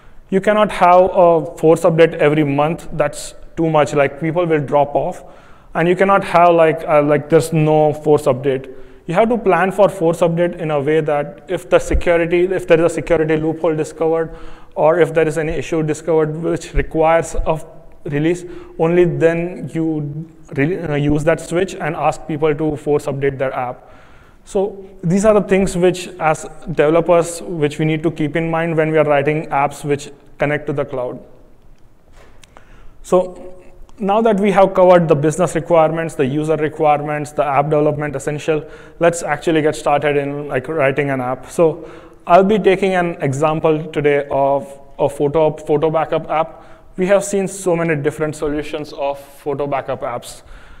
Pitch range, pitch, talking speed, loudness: 150-170 Hz, 160 Hz, 175 wpm, -16 LUFS